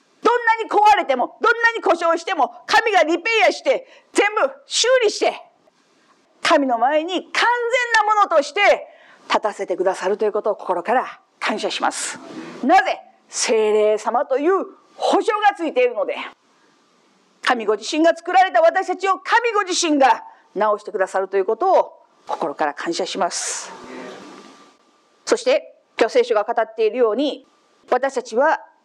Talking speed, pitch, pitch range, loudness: 295 characters per minute, 335 Hz, 255-420 Hz, -19 LUFS